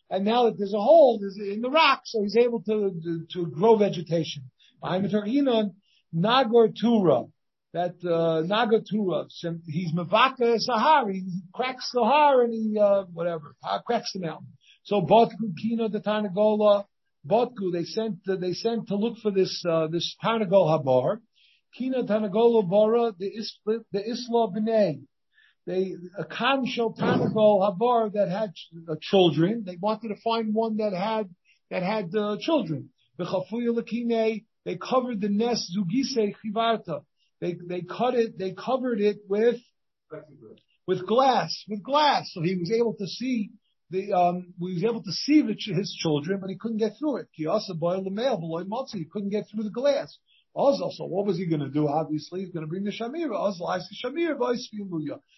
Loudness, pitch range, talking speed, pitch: -25 LUFS, 180-230 Hz, 155 wpm, 210 Hz